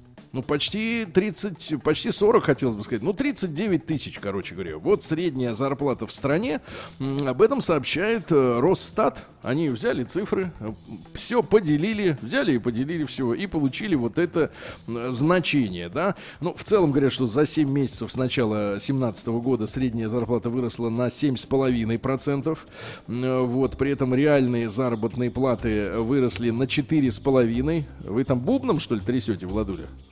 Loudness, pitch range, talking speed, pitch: -24 LUFS, 120-155 Hz, 140 wpm, 130 Hz